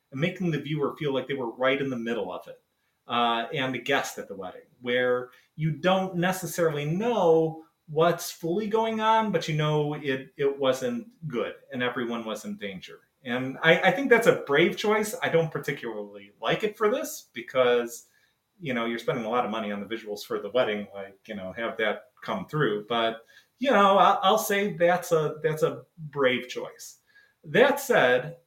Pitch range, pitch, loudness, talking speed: 120-180 Hz, 150 Hz, -26 LUFS, 195 wpm